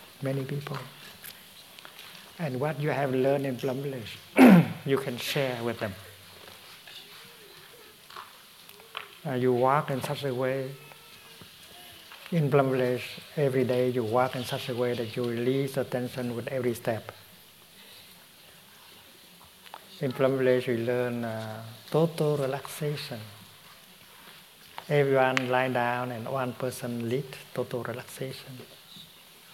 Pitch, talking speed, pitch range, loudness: 130 Hz, 120 wpm, 125-140 Hz, -28 LUFS